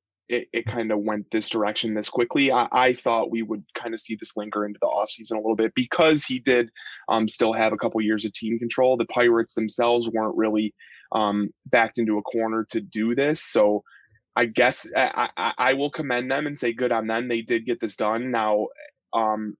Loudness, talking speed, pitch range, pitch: -24 LUFS, 215 wpm, 110-120 Hz, 115 Hz